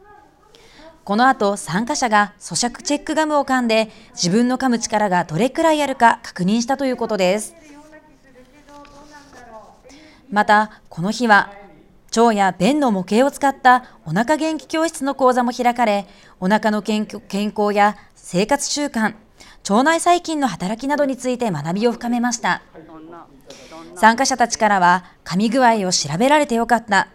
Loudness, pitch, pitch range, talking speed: -18 LUFS, 235 Hz, 205-275 Hz, 280 characters per minute